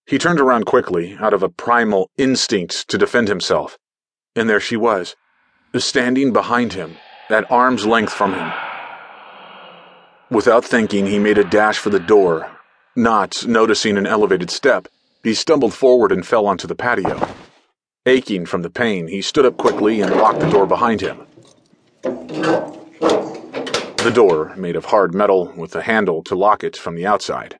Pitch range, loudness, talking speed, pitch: 100-125 Hz, -17 LUFS, 165 wpm, 110 Hz